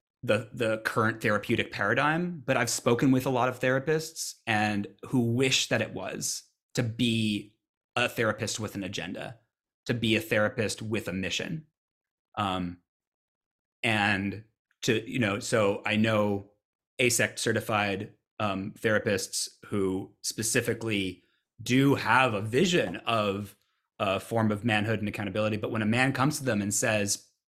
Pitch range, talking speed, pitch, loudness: 105-125 Hz, 145 wpm, 110 Hz, -28 LUFS